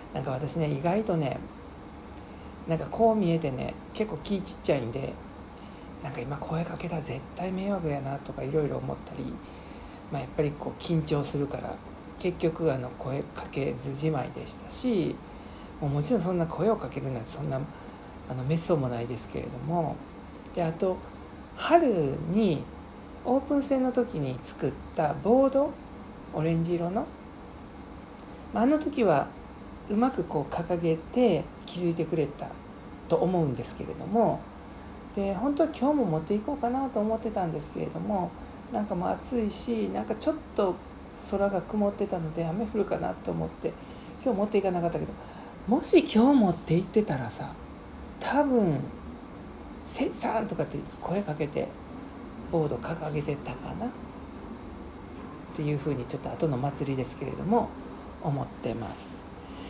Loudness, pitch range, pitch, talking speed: -29 LUFS, 150-220 Hz, 170 Hz, 305 characters per minute